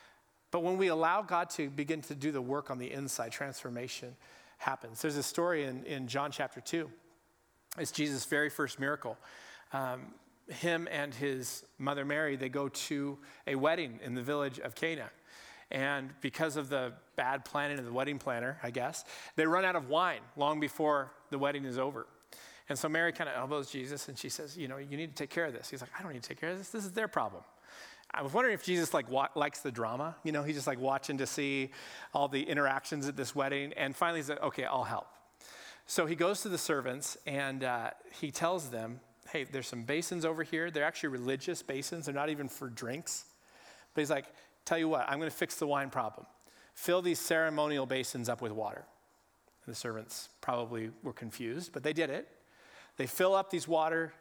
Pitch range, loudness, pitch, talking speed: 135-160 Hz, -35 LUFS, 145 Hz, 215 wpm